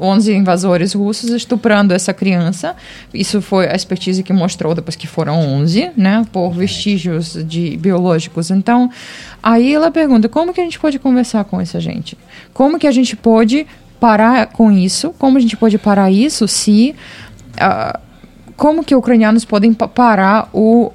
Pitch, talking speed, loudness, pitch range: 215 Hz, 165 wpm, -13 LUFS, 185-240 Hz